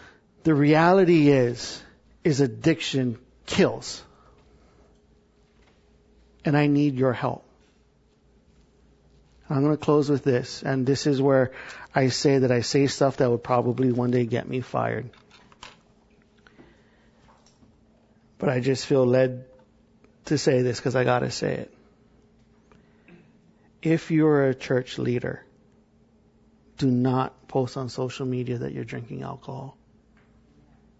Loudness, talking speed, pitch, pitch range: -24 LUFS, 125 wpm, 130 Hz, 125-145 Hz